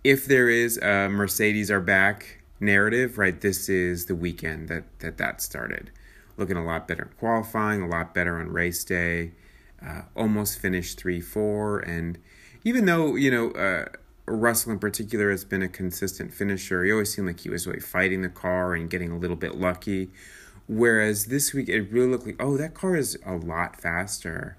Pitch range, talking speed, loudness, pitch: 90-110 Hz, 190 wpm, -25 LUFS, 95 Hz